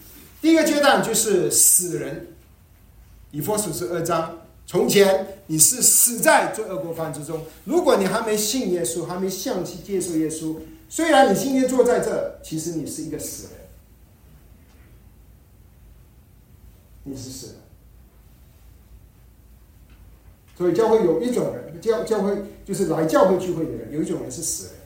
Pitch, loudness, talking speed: 165 Hz, -20 LUFS, 215 characters per minute